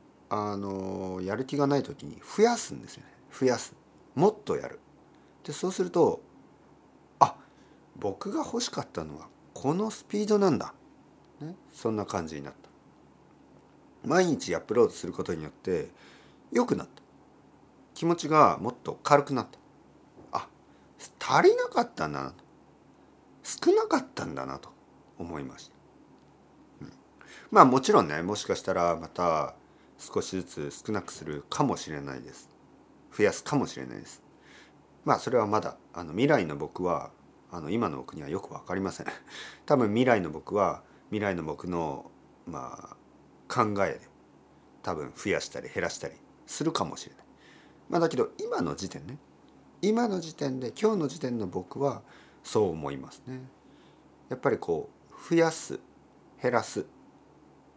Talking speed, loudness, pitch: 280 characters per minute, -29 LUFS, 135 Hz